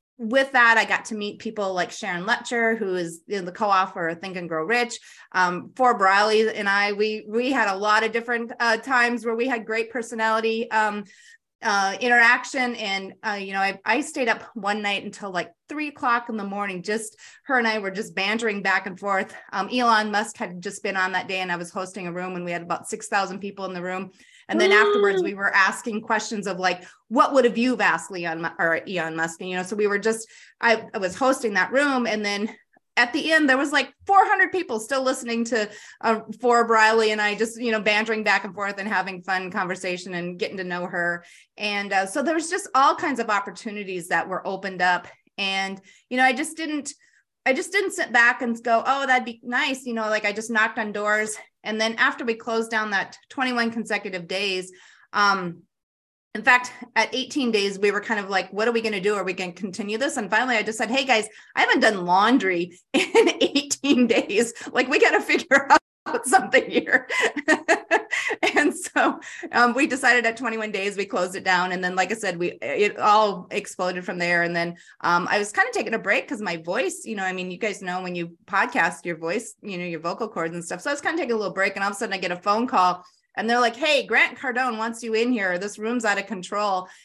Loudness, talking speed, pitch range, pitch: -23 LUFS, 235 wpm, 190-245 Hz, 215 Hz